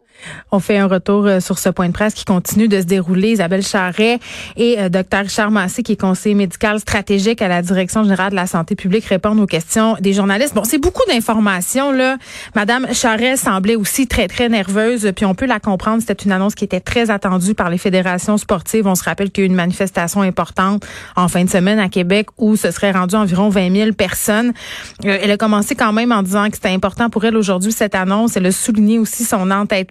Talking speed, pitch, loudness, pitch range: 225 wpm, 205 Hz, -15 LUFS, 190-220 Hz